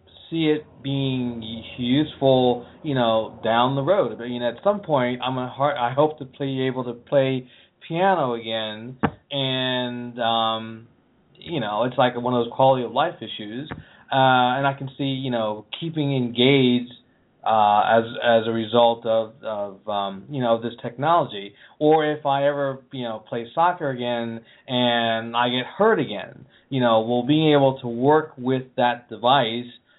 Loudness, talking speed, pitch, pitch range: -22 LUFS, 170 wpm, 125 Hz, 115-140 Hz